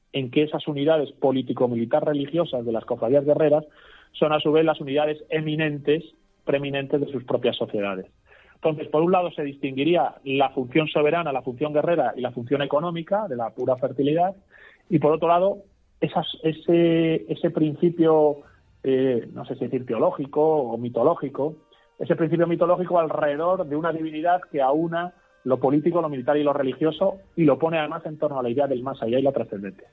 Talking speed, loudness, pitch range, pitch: 175 wpm, -23 LUFS, 135-165 Hz, 150 Hz